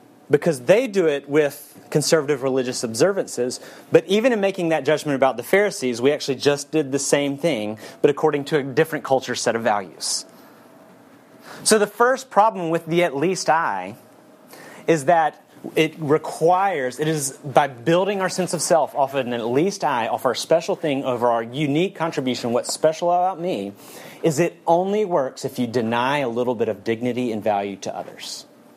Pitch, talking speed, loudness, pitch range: 155 Hz, 185 wpm, -21 LUFS, 130-175 Hz